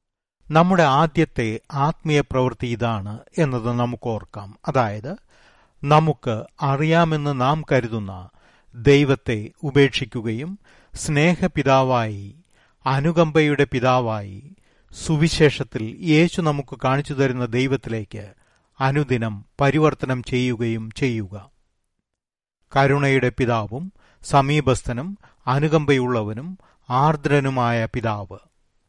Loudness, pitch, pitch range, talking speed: -21 LUFS, 130 Hz, 115-150 Hz, 70 wpm